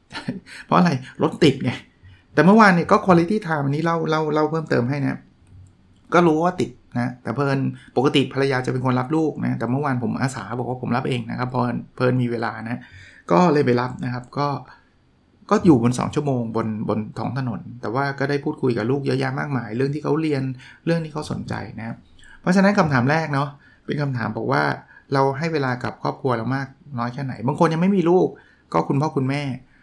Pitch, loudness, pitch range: 135 Hz, -21 LUFS, 120-150 Hz